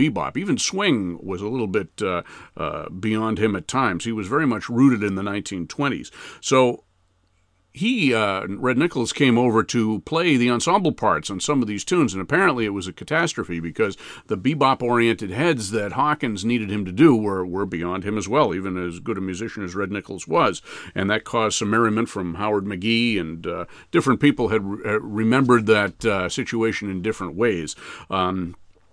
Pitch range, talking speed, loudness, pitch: 95-120 Hz, 190 wpm, -22 LUFS, 105 Hz